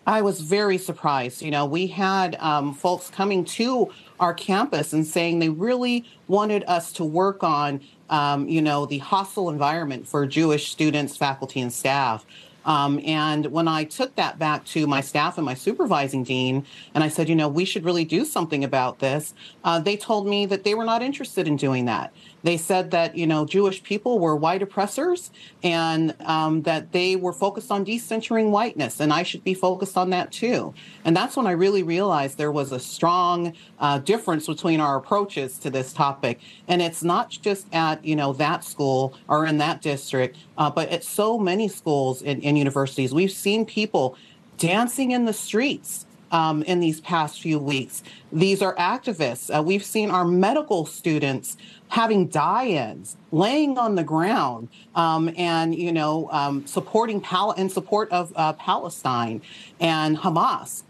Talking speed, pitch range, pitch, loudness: 180 wpm, 150-195 Hz, 170 Hz, -23 LUFS